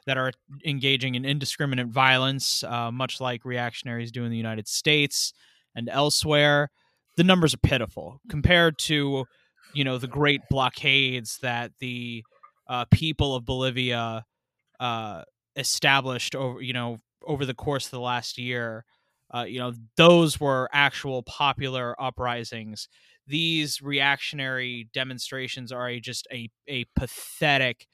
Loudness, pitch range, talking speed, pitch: -25 LUFS, 120-140 Hz, 135 wpm, 130 Hz